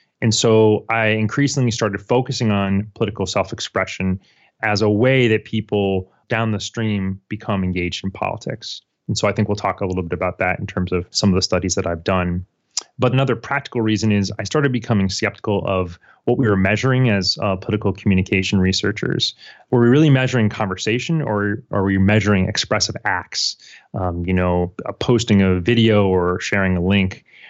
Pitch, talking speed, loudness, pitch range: 105 Hz, 180 wpm, -19 LUFS, 95-115 Hz